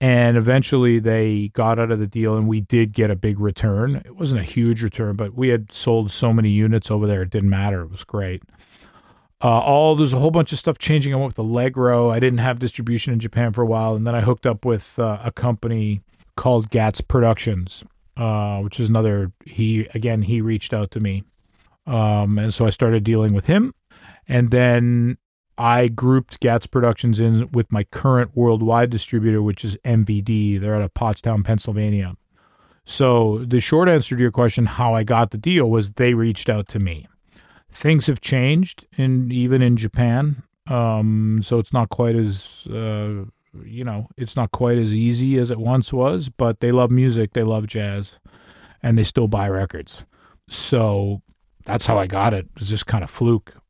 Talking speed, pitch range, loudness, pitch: 195 wpm, 105-125 Hz, -19 LUFS, 115 Hz